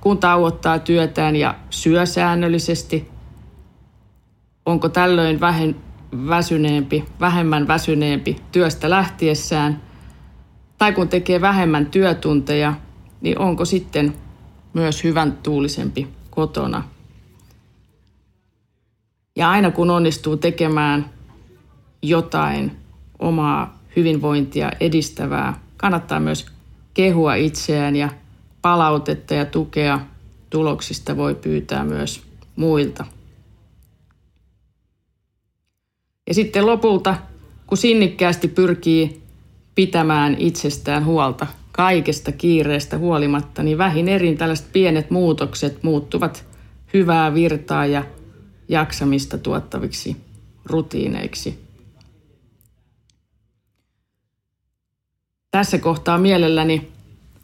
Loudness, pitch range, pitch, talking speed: -19 LUFS, 110-170 Hz, 150 Hz, 80 wpm